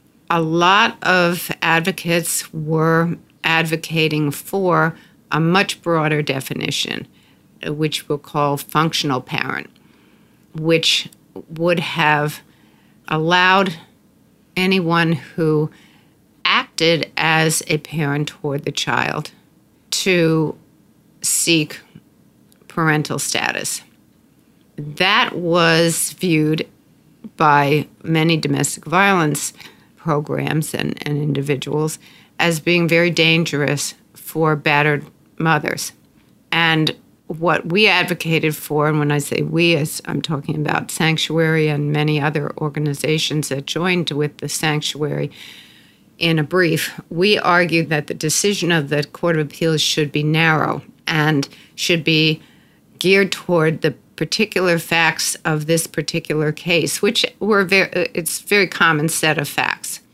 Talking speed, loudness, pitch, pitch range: 115 wpm, -18 LUFS, 160 Hz, 150-170 Hz